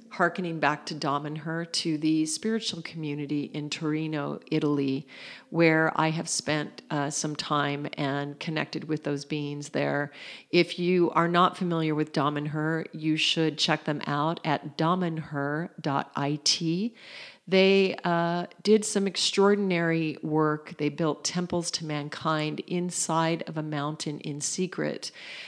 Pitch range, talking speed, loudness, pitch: 150-175 Hz, 130 wpm, -27 LUFS, 155 Hz